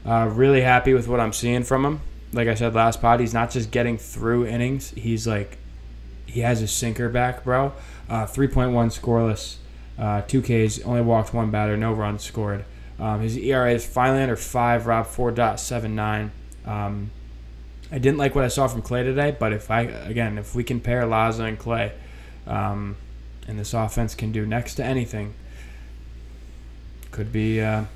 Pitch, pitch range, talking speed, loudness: 115 Hz, 100-120 Hz, 175 wpm, -23 LUFS